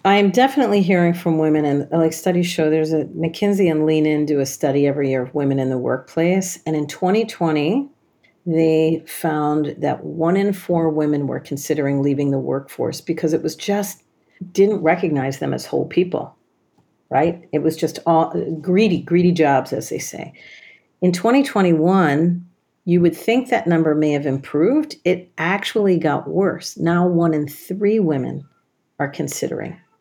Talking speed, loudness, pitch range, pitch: 165 wpm, -19 LUFS, 150-185 Hz, 165 Hz